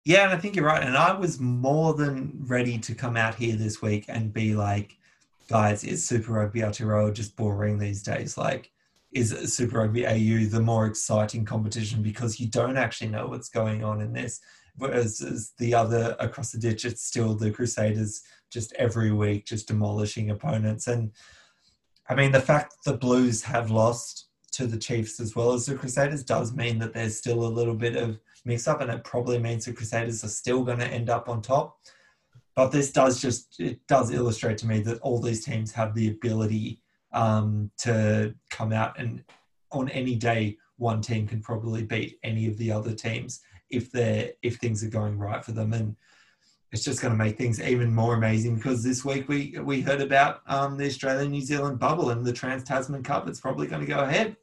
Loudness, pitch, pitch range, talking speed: -27 LUFS, 115 Hz, 110-125 Hz, 200 wpm